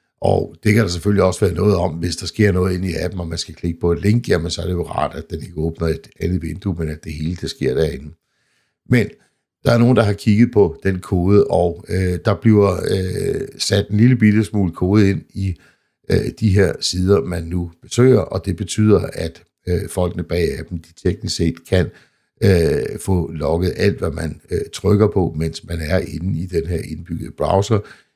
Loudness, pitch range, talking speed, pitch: -18 LUFS, 85-105 Hz, 220 wpm, 90 Hz